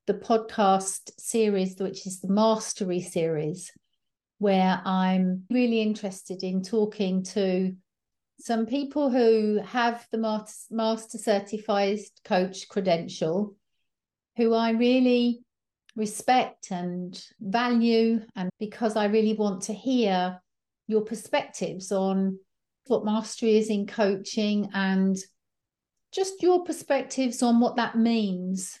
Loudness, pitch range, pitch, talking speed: -26 LUFS, 190-230 Hz, 215 Hz, 110 wpm